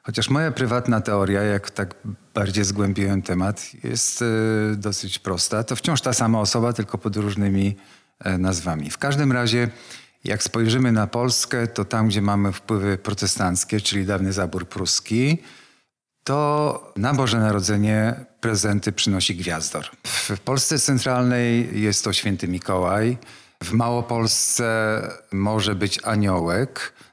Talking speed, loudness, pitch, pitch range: 125 wpm, -22 LUFS, 105 Hz, 100-120 Hz